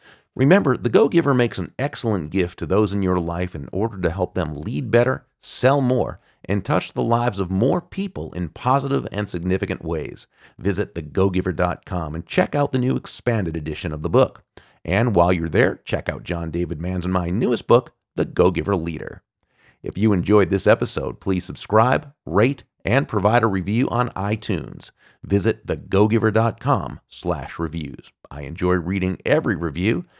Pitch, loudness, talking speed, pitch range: 95 Hz, -21 LUFS, 165 wpm, 90-115 Hz